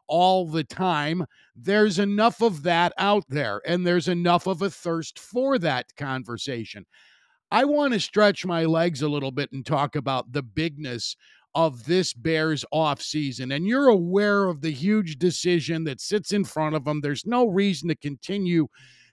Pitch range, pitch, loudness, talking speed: 145-195 Hz, 165 Hz, -24 LUFS, 175 wpm